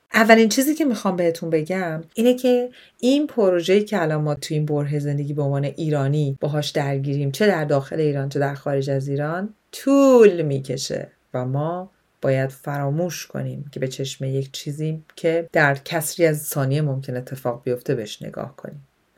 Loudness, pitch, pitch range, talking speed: -21 LUFS, 150 Hz, 140-180 Hz, 170 wpm